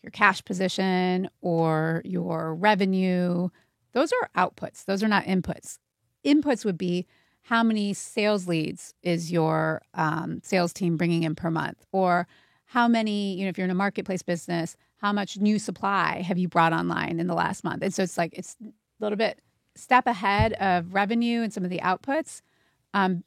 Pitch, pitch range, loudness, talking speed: 185 Hz, 170-210 Hz, -26 LUFS, 180 wpm